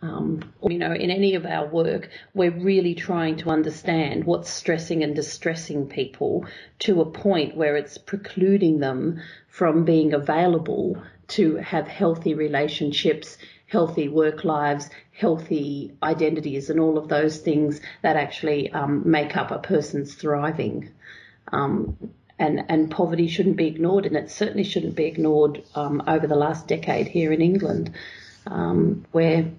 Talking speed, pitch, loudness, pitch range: 150 wpm, 160 Hz, -23 LUFS, 150-170 Hz